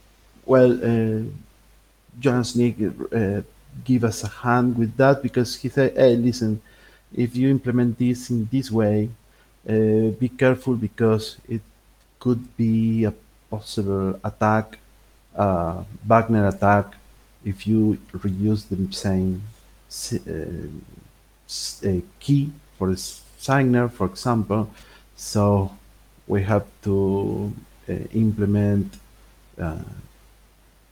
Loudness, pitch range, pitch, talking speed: -22 LUFS, 100-120 Hz, 110 Hz, 110 wpm